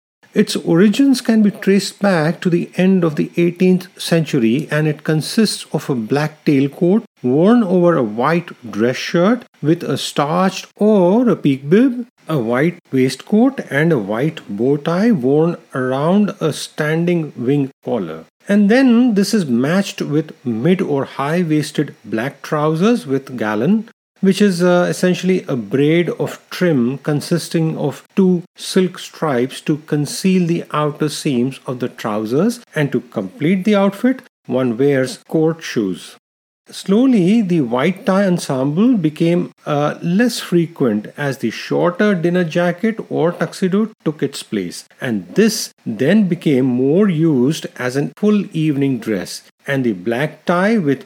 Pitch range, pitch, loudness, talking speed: 140-195 Hz, 170 Hz, -17 LUFS, 145 wpm